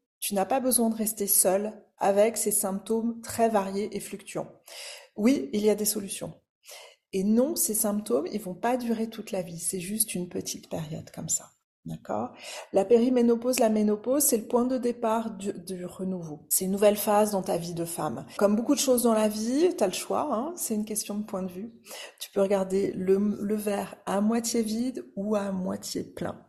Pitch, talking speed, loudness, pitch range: 210 Hz, 210 wpm, -27 LUFS, 195-230 Hz